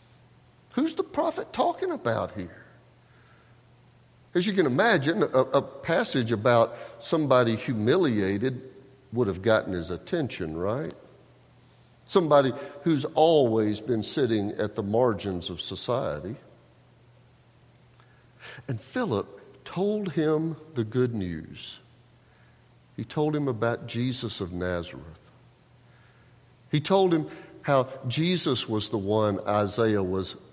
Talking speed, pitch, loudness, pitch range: 110 wpm, 125 Hz, -26 LUFS, 110-145 Hz